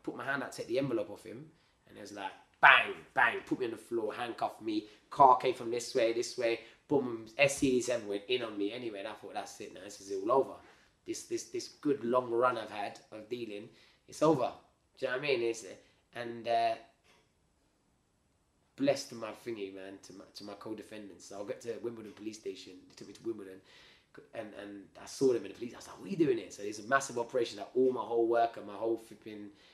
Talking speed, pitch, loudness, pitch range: 235 wpm, 115 Hz, -33 LUFS, 110-145 Hz